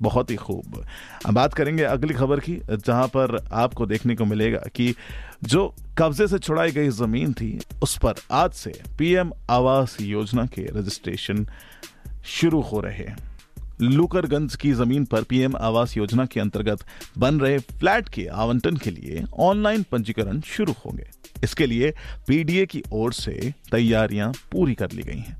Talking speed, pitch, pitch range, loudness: 160 wpm, 120 Hz, 110-145 Hz, -23 LUFS